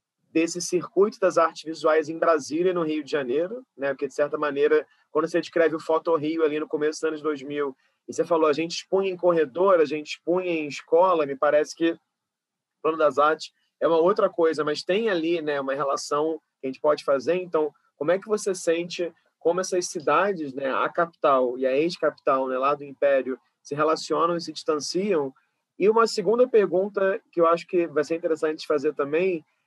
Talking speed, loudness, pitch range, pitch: 200 wpm, -24 LUFS, 150-175 Hz, 160 Hz